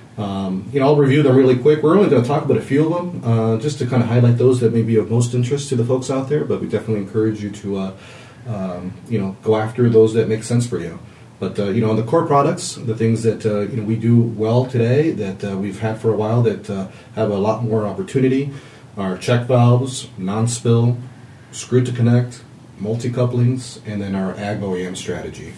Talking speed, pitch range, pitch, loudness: 240 wpm, 110-125 Hz, 115 Hz, -18 LUFS